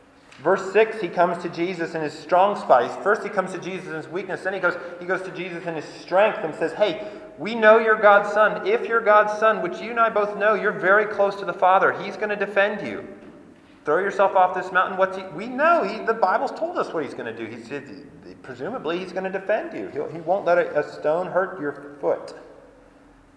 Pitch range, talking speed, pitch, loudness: 175-215 Hz, 240 wpm, 190 Hz, -22 LUFS